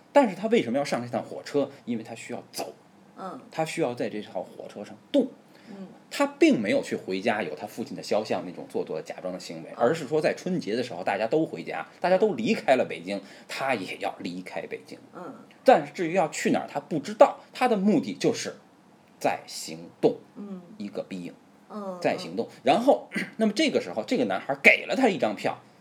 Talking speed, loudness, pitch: 305 characters per minute, -27 LUFS, 200 Hz